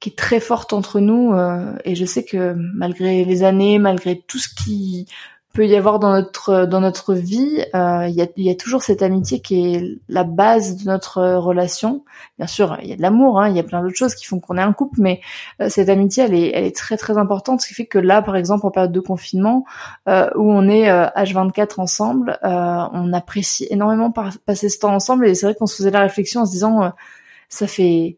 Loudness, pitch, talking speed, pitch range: -17 LUFS, 195 Hz, 245 wpm, 180-210 Hz